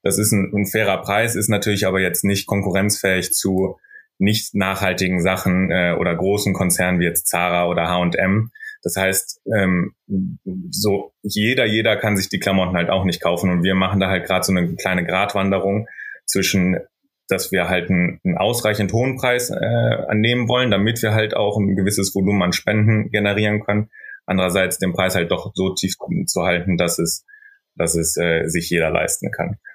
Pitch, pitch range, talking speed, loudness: 95 Hz, 90-105 Hz, 180 wpm, -19 LUFS